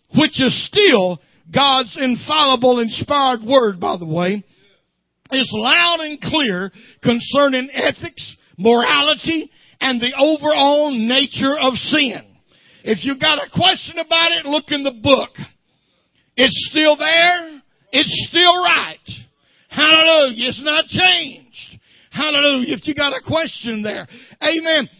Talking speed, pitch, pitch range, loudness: 125 wpm, 280 Hz, 250-310 Hz, -15 LUFS